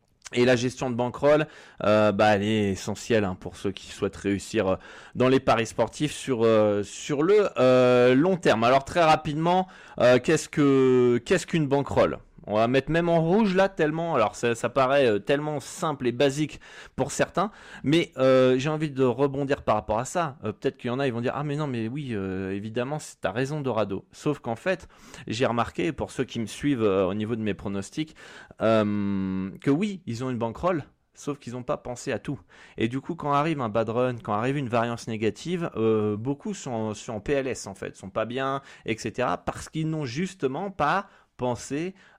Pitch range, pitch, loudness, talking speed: 110-150 Hz, 130 Hz, -25 LUFS, 205 wpm